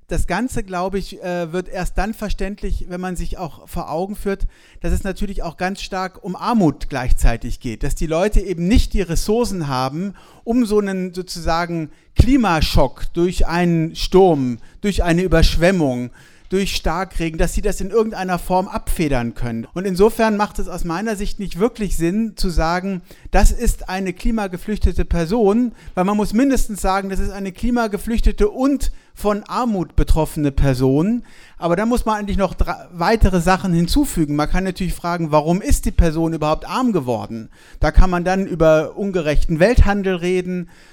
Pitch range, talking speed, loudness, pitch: 165-205 Hz, 165 wpm, -20 LUFS, 185 Hz